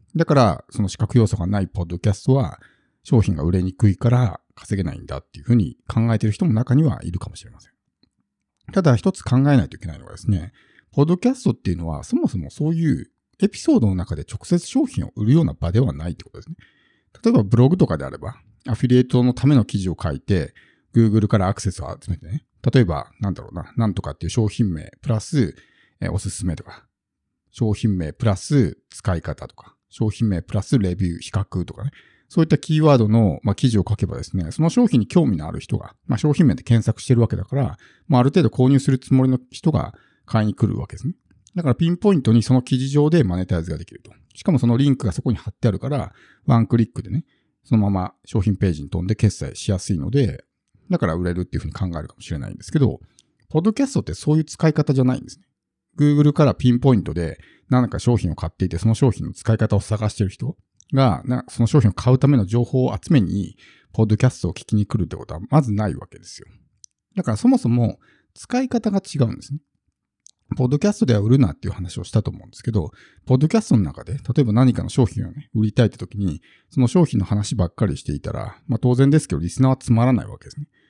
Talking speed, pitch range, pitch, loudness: 465 characters per minute, 100-135 Hz, 115 Hz, -20 LUFS